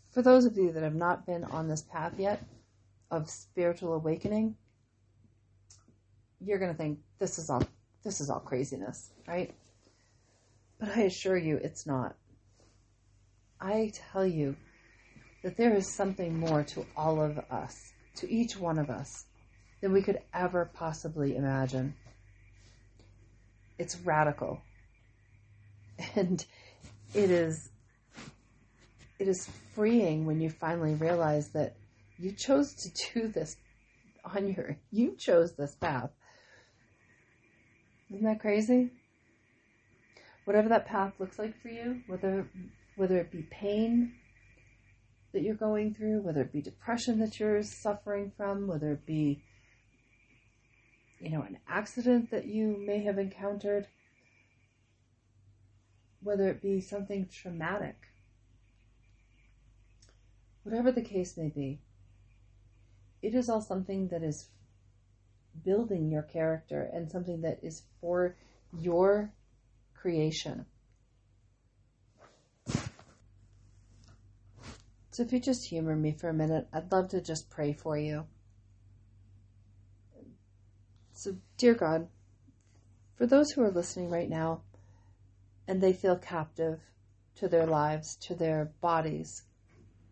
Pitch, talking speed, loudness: 150 Hz, 120 wpm, -32 LUFS